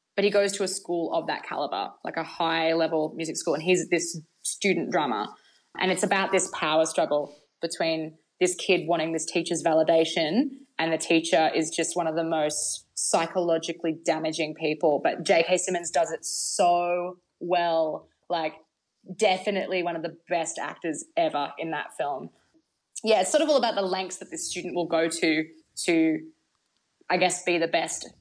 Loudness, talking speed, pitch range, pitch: -26 LUFS, 175 wpm, 160-185 Hz, 170 Hz